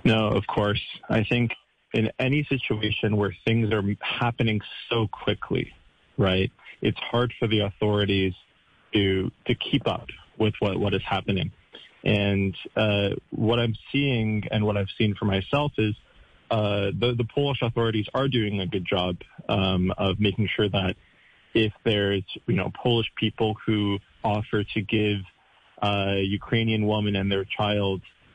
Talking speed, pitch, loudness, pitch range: 155 wpm, 105 Hz, -25 LUFS, 100-115 Hz